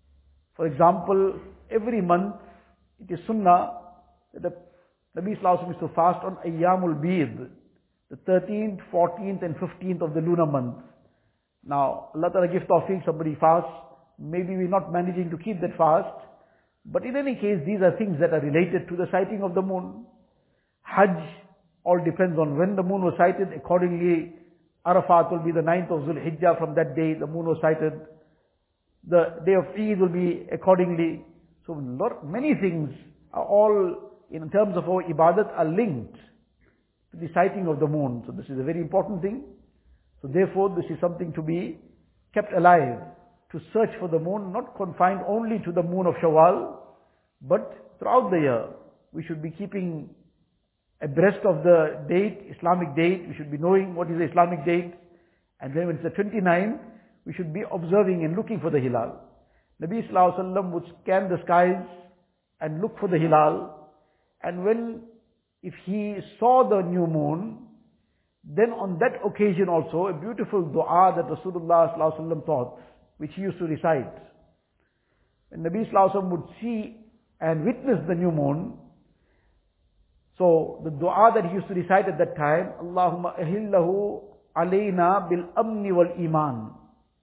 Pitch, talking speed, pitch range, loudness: 175 Hz, 170 wpm, 165-195 Hz, -24 LUFS